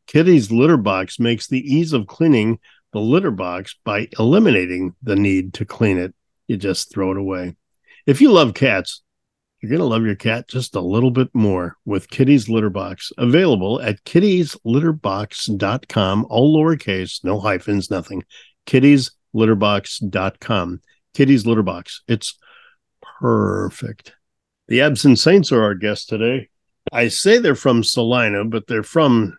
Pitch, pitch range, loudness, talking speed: 110 Hz, 100-130 Hz, -17 LUFS, 145 wpm